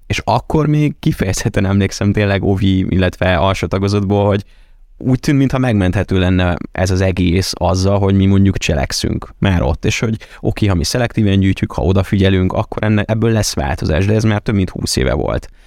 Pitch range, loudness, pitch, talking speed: 95-110 Hz, -15 LUFS, 100 Hz, 180 wpm